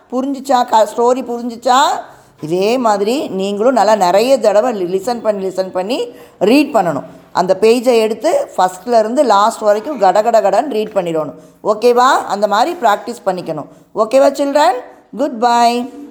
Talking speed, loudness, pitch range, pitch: 135 wpm, -14 LUFS, 195-255 Hz, 225 Hz